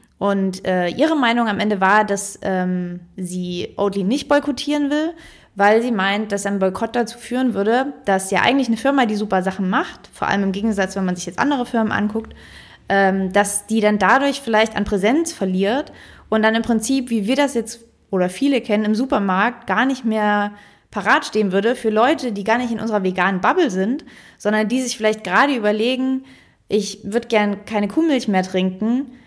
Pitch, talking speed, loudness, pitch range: 215 Hz, 195 wpm, -19 LUFS, 200-250 Hz